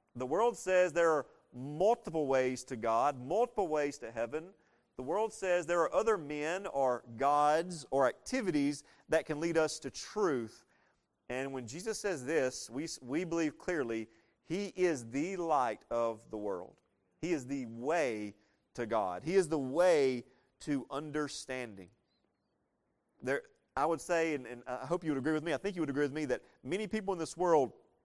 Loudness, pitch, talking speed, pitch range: -34 LUFS, 150 Hz, 180 wpm, 130-175 Hz